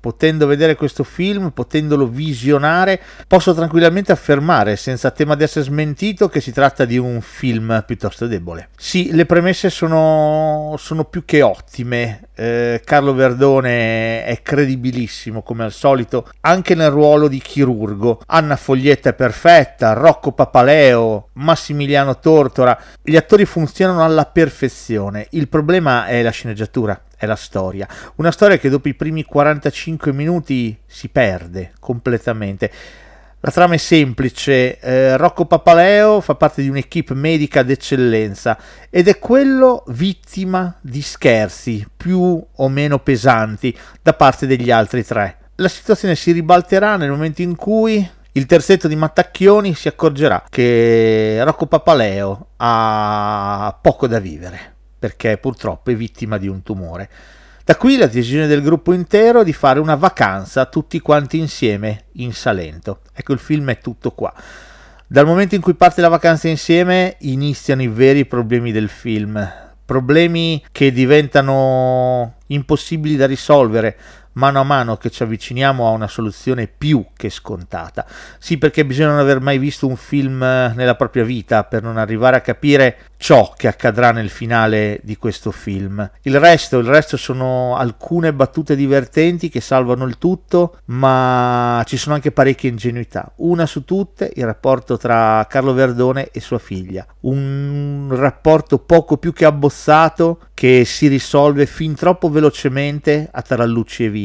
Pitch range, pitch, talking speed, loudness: 120-160 Hz, 135 Hz, 145 wpm, -14 LUFS